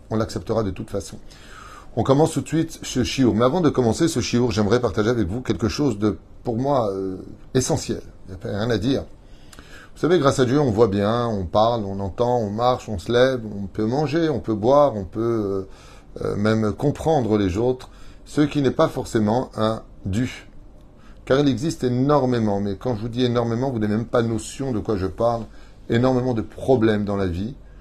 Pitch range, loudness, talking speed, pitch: 105-130 Hz, -22 LUFS, 215 wpm, 115 Hz